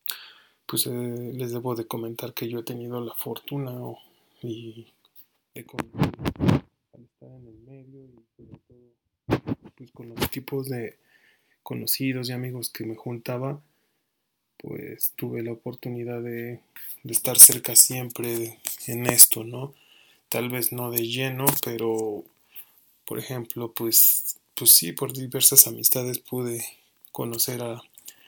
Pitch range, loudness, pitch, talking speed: 115-125 Hz, -20 LUFS, 120 Hz, 135 wpm